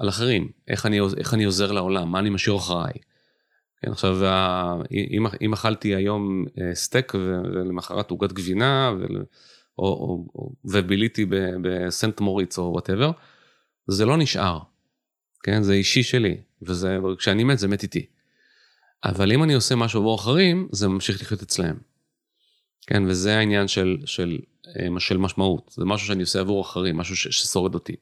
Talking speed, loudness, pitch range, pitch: 150 wpm, -23 LUFS, 95-110 Hz, 100 Hz